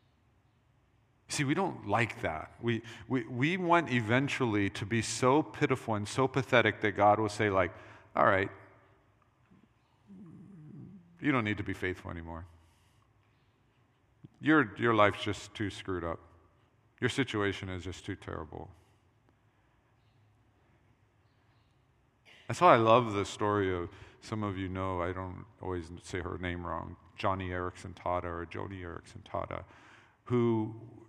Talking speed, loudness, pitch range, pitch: 135 wpm, -31 LUFS, 95-120 Hz, 110 Hz